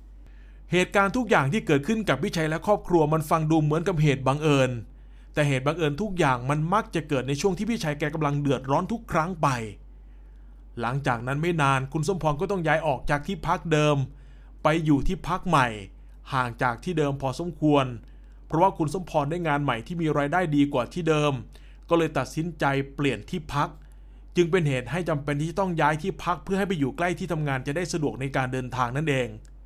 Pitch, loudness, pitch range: 150 Hz, -25 LUFS, 135-175 Hz